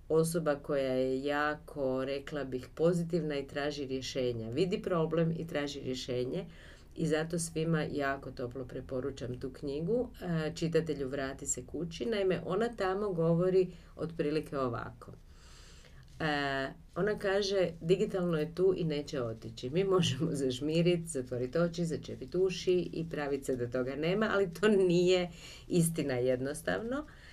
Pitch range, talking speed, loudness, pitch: 130-175 Hz, 135 wpm, -33 LUFS, 150 Hz